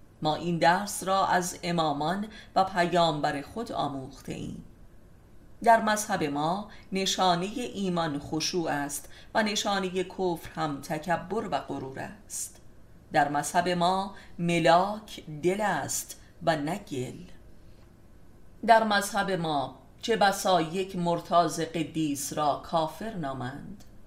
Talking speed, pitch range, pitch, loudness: 115 wpm, 145-190 Hz, 170 Hz, -28 LUFS